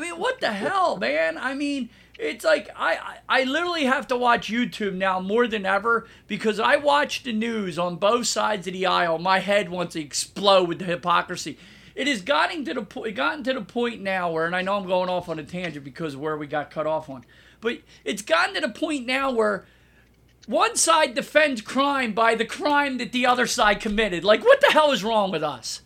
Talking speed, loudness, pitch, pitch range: 225 wpm, -23 LUFS, 220 Hz, 185-265 Hz